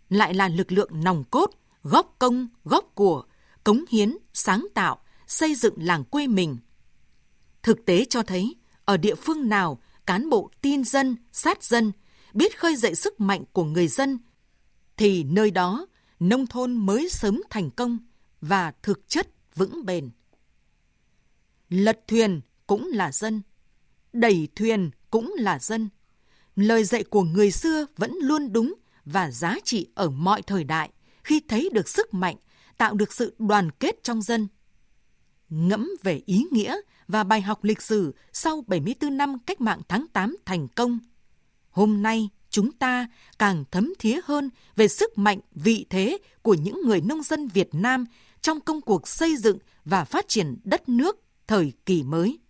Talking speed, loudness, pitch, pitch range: 165 wpm, -24 LUFS, 215 Hz, 190-250 Hz